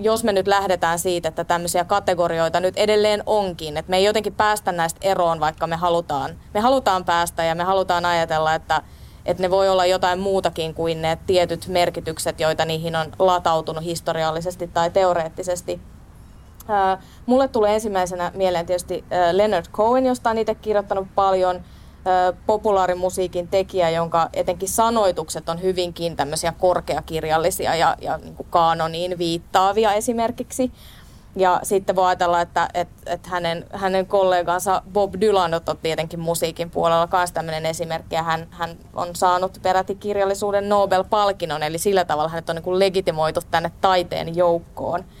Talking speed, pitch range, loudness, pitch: 145 wpm, 165-195 Hz, -21 LUFS, 180 Hz